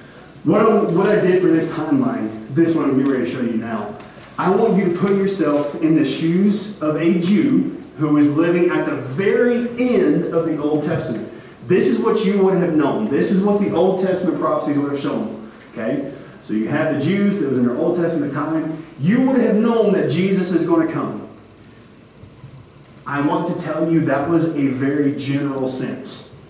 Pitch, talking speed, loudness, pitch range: 160 Hz, 210 wpm, -18 LUFS, 145-190 Hz